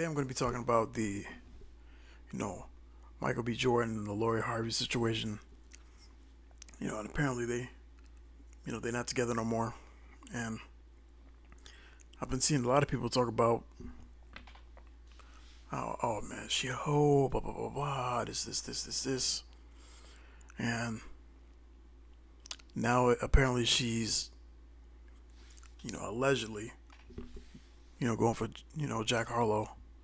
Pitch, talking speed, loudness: 80 Hz, 140 wpm, -34 LUFS